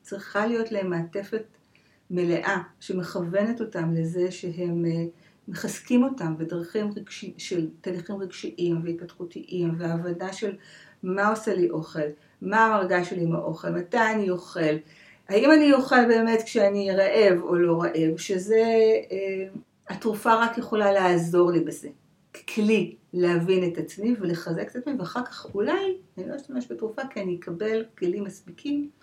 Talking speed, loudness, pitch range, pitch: 140 wpm, -25 LUFS, 175-220 Hz, 190 Hz